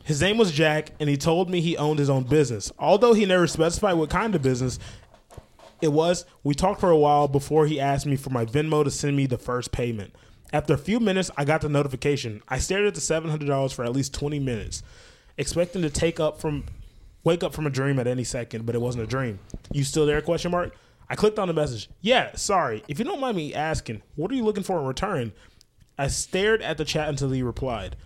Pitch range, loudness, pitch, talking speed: 130-165 Hz, -24 LUFS, 150 Hz, 235 wpm